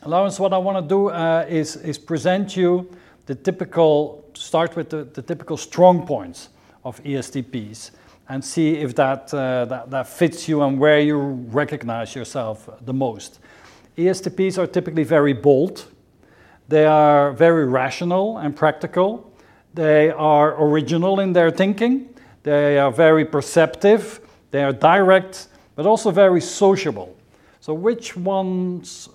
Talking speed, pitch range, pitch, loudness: 140 wpm, 140-180 Hz, 155 Hz, -18 LUFS